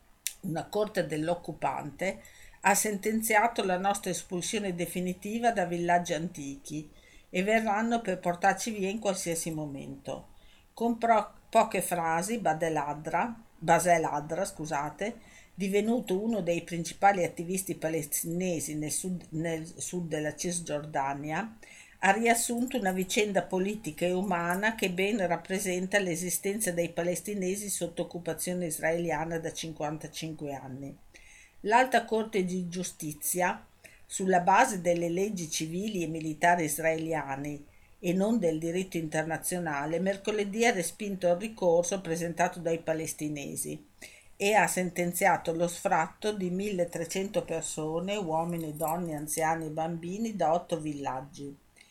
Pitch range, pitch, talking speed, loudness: 160-195 Hz, 175 Hz, 115 wpm, -30 LUFS